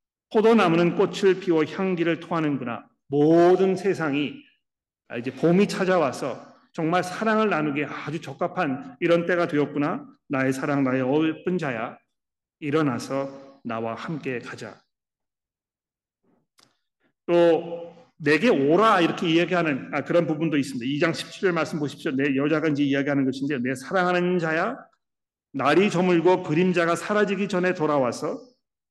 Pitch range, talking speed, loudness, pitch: 145-180 Hz, 295 characters per minute, -23 LUFS, 165 Hz